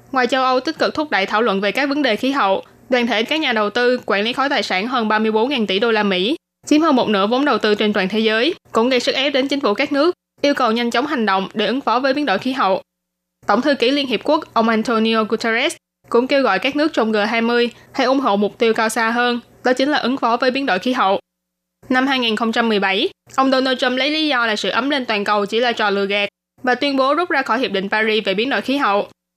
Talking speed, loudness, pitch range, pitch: 270 wpm, -17 LUFS, 210-265 Hz, 235 Hz